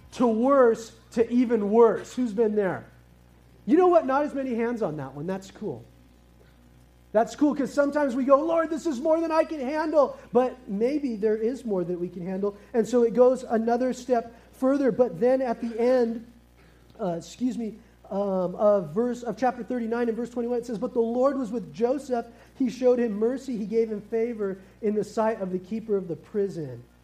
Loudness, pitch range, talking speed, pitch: -25 LUFS, 200-250 Hz, 205 wpm, 230 Hz